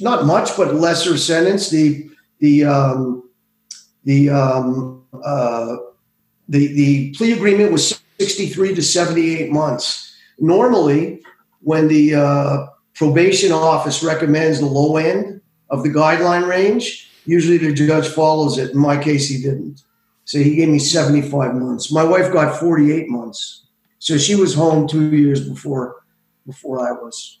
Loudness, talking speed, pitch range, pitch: -16 LUFS, 140 wpm, 140-170 Hz, 155 Hz